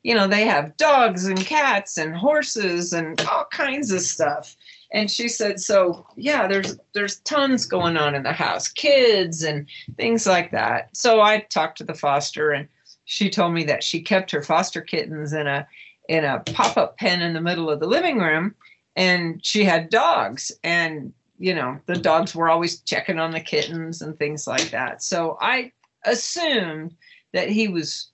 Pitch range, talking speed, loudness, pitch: 160-210 Hz, 185 wpm, -21 LUFS, 180 Hz